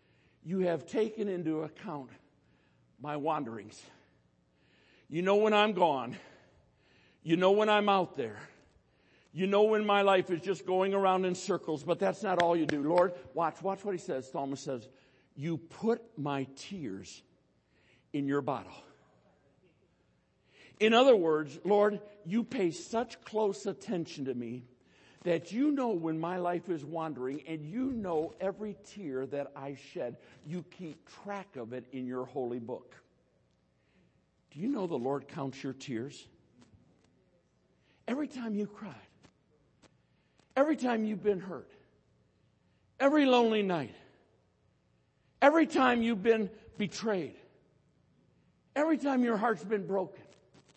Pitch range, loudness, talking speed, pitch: 140-205 Hz, -32 LUFS, 140 wpm, 175 Hz